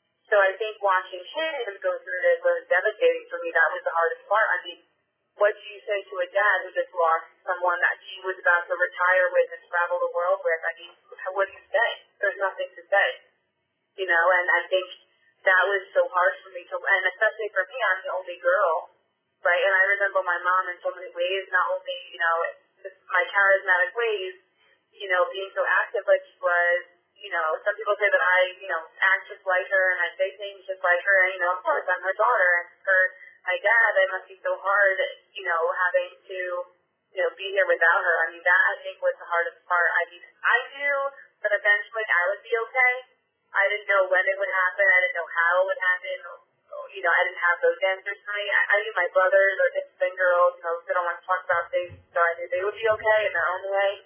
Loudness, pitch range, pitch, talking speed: -23 LUFS, 180-205 Hz, 190 Hz, 240 wpm